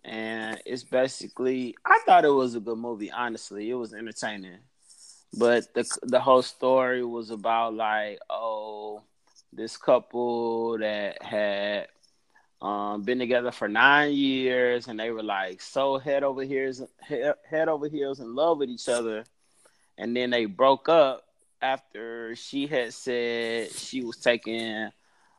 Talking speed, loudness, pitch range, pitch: 145 wpm, -26 LUFS, 110-130 Hz, 120 Hz